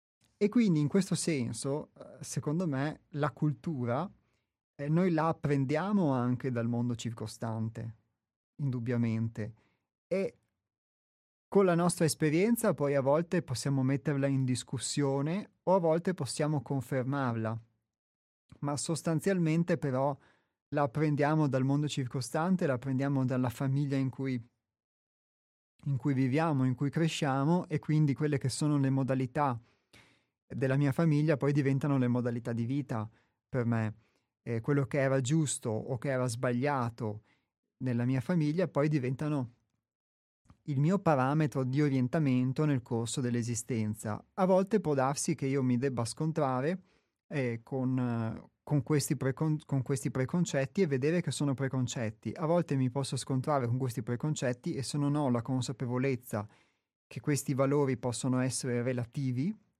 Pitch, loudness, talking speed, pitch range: 135 Hz, -32 LUFS, 140 wpm, 125-150 Hz